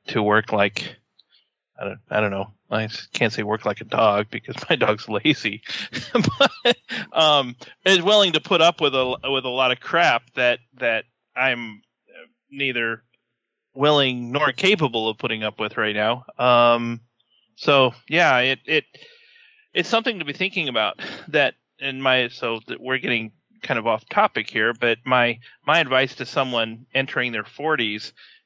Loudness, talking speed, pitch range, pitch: -21 LUFS, 165 wpm, 115-150 Hz, 125 Hz